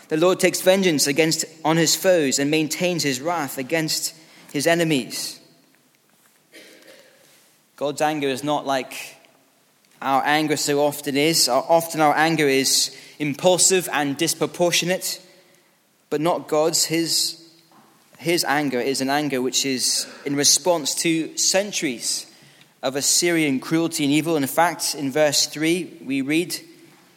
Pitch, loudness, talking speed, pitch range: 155 Hz, -20 LUFS, 130 wpm, 145-170 Hz